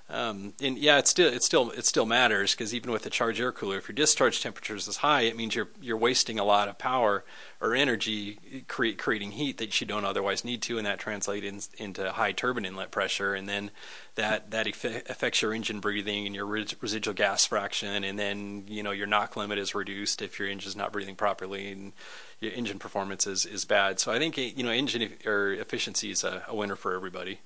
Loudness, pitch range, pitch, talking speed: -28 LUFS, 100-115 Hz, 105 Hz, 230 wpm